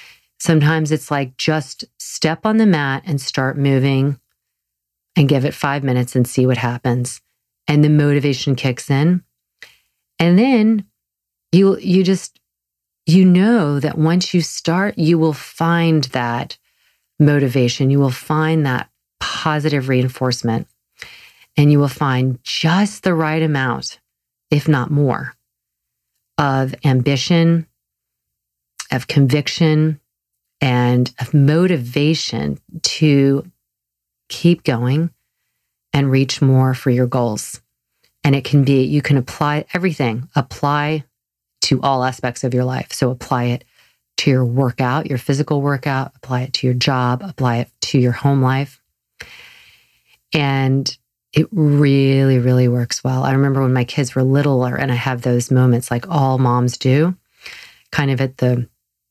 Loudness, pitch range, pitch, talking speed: -17 LUFS, 125-150 Hz, 135 Hz, 135 wpm